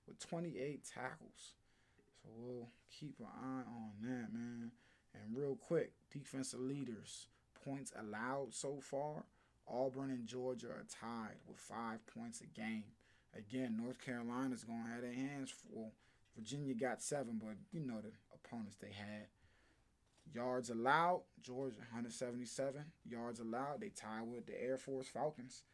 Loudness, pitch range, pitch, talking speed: -46 LUFS, 115-135 Hz, 120 Hz, 140 wpm